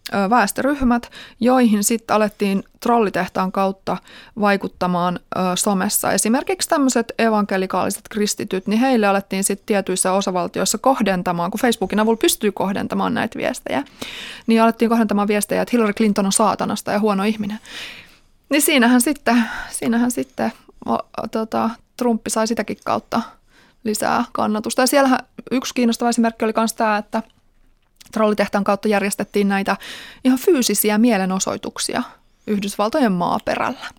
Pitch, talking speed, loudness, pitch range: 215 Hz, 125 wpm, -19 LUFS, 195-235 Hz